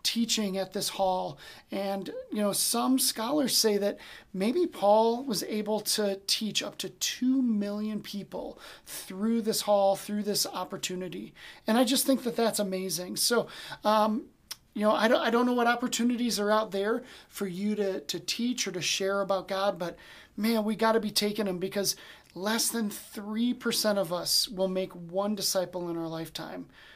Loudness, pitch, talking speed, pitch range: -28 LUFS, 210 Hz, 180 wpm, 195-230 Hz